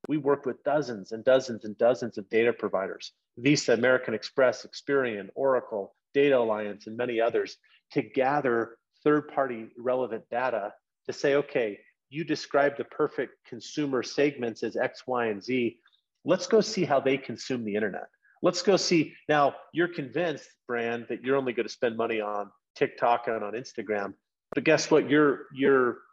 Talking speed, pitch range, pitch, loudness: 165 wpm, 115-145 Hz, 130 Hz, -28 LUFS